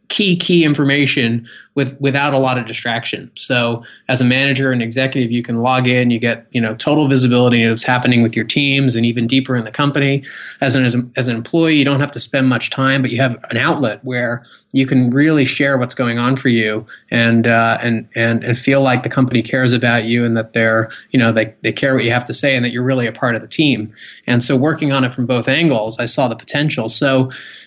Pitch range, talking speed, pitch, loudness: 115-135 Hz, 240 wpm, 125 Hz, -15 LUFS